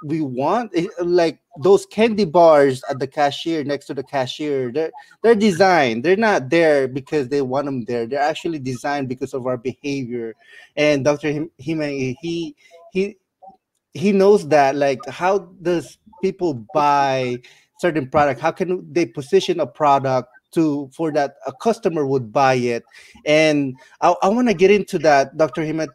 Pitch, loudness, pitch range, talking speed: 150 Hz, -19 LUFS, 140-175 Hz, 160 wpm